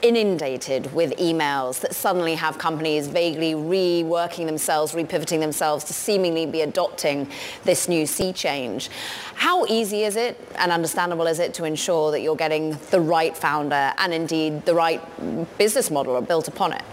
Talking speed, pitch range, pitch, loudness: 160 wpm, 155-175 Hz, 165 Hz, -22 LUFS